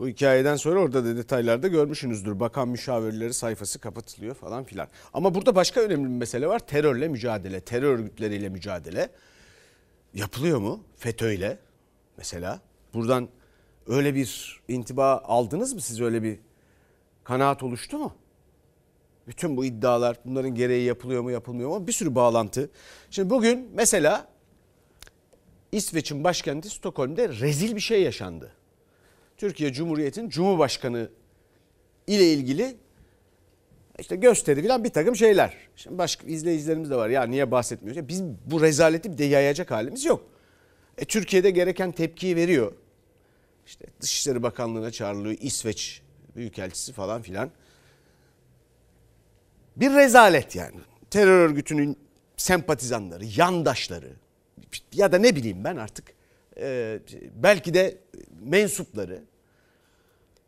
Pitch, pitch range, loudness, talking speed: 140 Hz, 120-180 Hz, -24 LUFS, 115 wpm